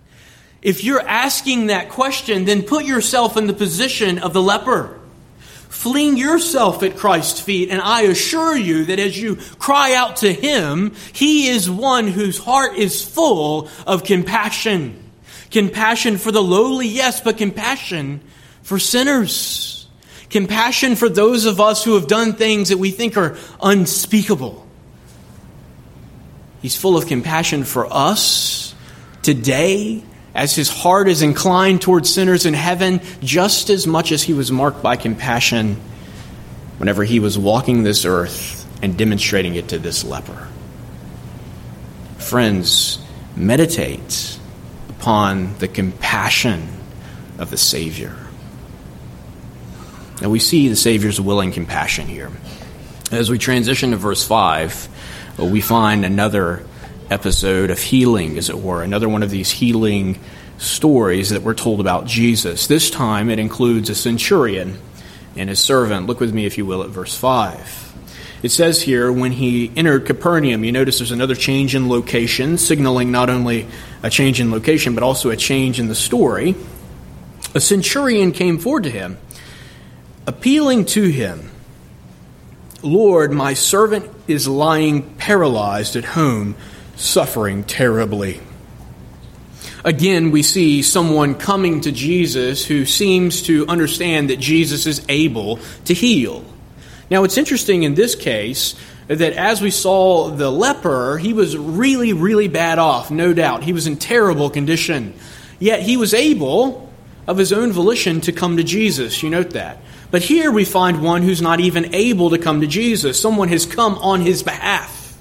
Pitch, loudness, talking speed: 160 Hz, -16 LUFS, 145 wpm